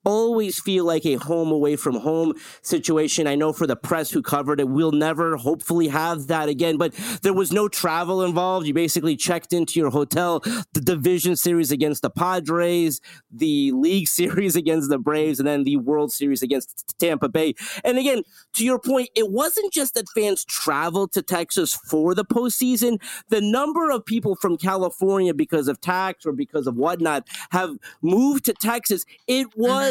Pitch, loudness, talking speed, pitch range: 175 Hz, -22 LUFS, 185 wpm, 155-220 Hz